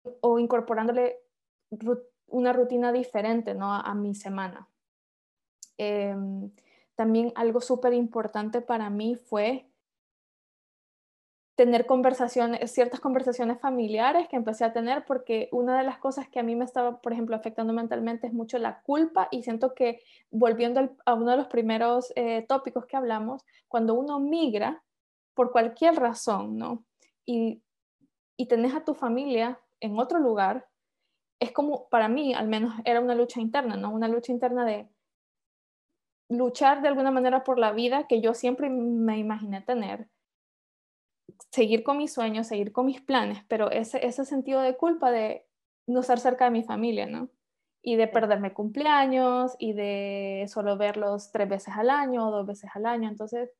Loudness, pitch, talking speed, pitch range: -27 LUFS, 240 Hz, 160 wpm, 225-255 Hz